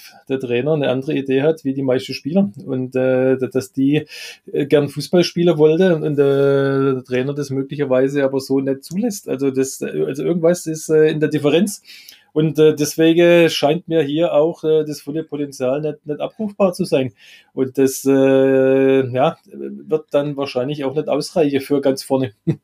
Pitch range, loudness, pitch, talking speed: 135-155 Hz, -18 LUFS, 145 Hz, 180 wpm